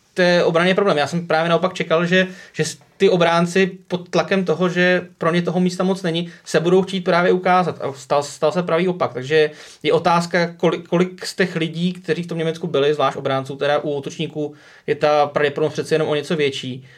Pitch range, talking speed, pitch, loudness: 150-180 Hz, 210 wpm, 165 Hz, -19 LUFS